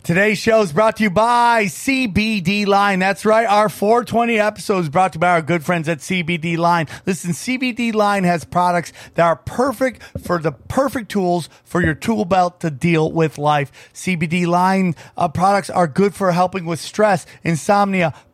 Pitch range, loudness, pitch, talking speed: 170-210 Hz, -17 LUFS, 185 Hz, 180 wpm